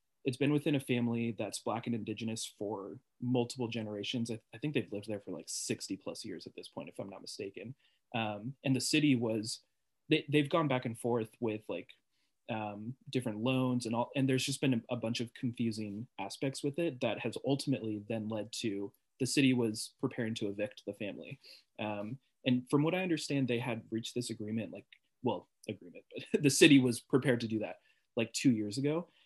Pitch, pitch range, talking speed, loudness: 120 Hz, 110-135 Hz, 205 wpm, -34 LUFS